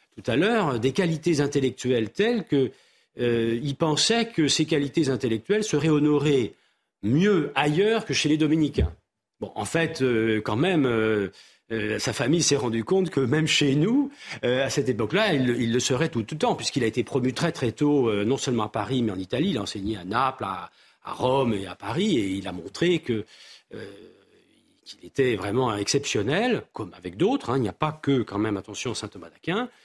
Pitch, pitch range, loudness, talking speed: 135 Hz, 115-155 Hz, -24 LUFS, 205 wpm